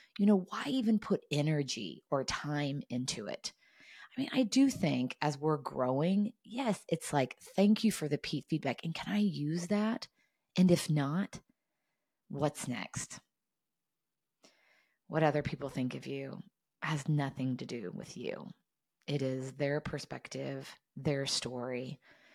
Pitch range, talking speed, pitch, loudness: 140-200 Hz, 145 wpm, 155 Hz, -34 LUFS